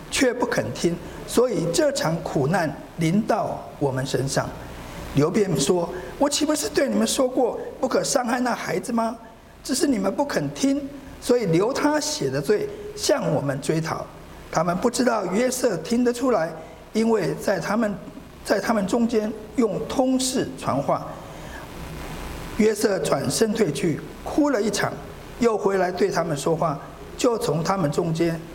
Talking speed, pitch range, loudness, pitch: 220 characters per minute, 175-260 Hz, -23 LUFS, 225 Hz